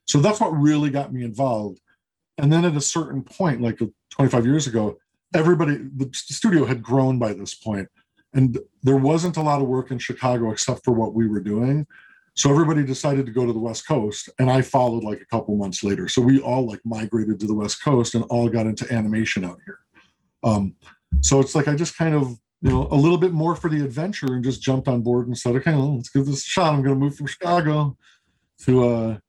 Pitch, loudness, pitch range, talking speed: 130 Hz, -21 LUFS, 115-145 Hz, 230 wpm